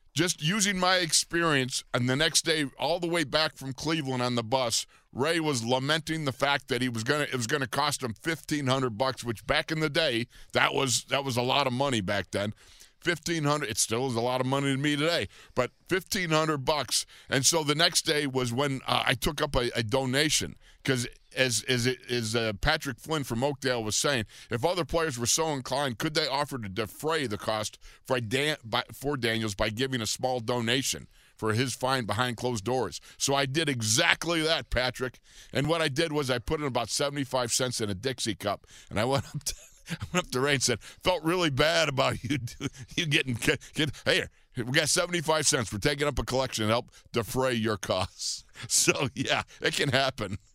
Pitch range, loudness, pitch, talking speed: 120-155 Hz, -28 LUFS, 135 Hz, 215 wpm